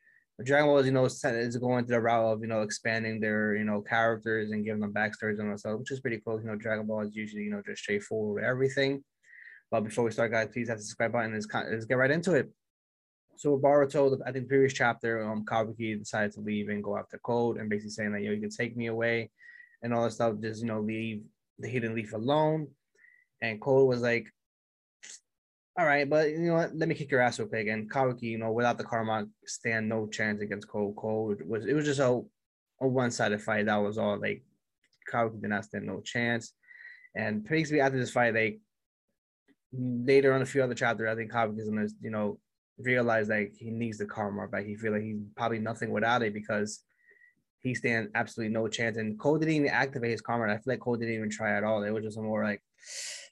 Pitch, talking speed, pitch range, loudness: 115 Hz, 240 wpm, 110-130 Hz, -30 LUFS